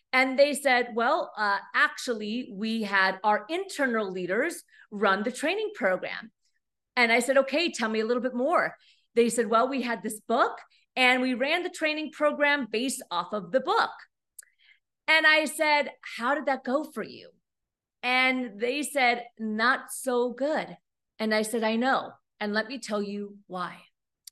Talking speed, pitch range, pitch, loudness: 170 wpm, 220-280 Hz, 250 Hz, -26 LUFS